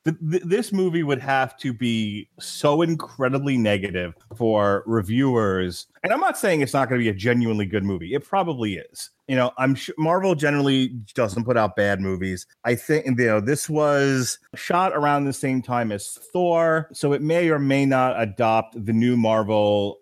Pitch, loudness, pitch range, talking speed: 130 Hz, -22 LUFS, 110-145 Hz, 185 wpm